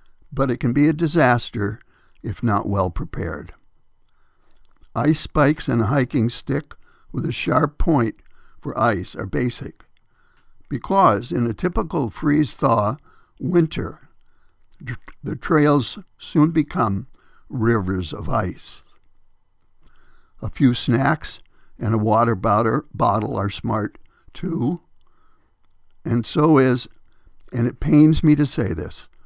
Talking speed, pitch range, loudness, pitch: 120 wpm, 100-145 Hz, -20 LUFS, 120 Hz